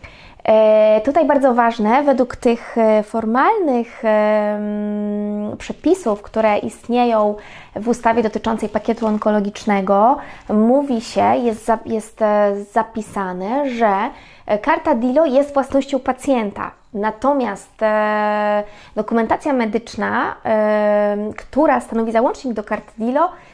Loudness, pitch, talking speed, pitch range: -18 LUFS, 225 Hz, 85 wpm, 210-255 Hz